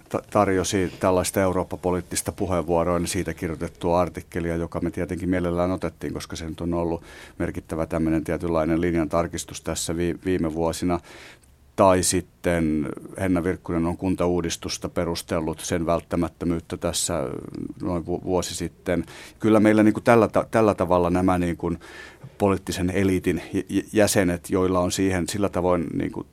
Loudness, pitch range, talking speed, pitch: -24 LUFS, 85-95 Hz, 130 wpm, 90 Hz